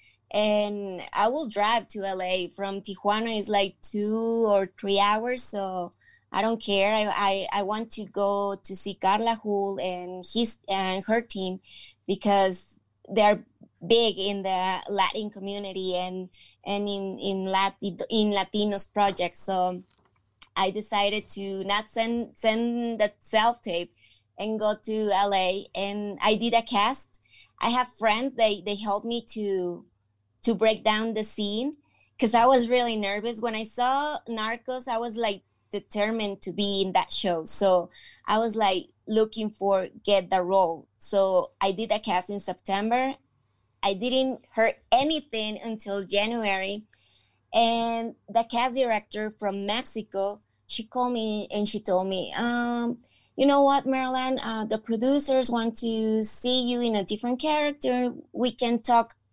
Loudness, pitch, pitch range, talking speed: -26 LUFS, 210 Hz, 195-230 Hz, 155 wpm